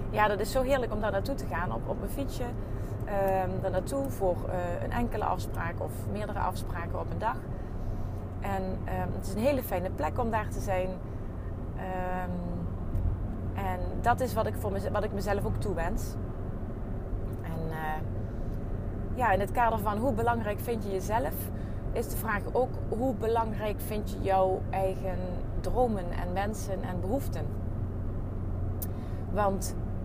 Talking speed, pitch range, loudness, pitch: 160 wpm, 95-105 Hz, -32 LUFS, 95 Hz